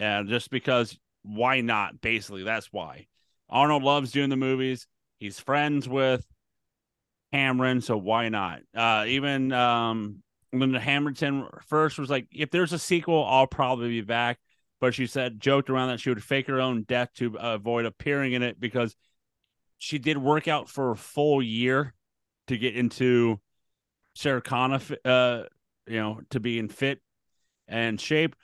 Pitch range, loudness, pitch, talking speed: 115-140 Hz, -26 LUFS, 125 Hz, 165 wpm